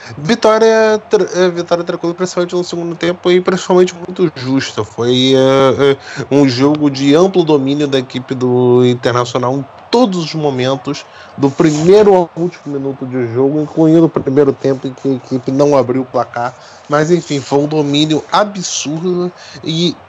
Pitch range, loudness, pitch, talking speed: 135-175 Hz, -13 LUFS, 150 Hz, 160 wpm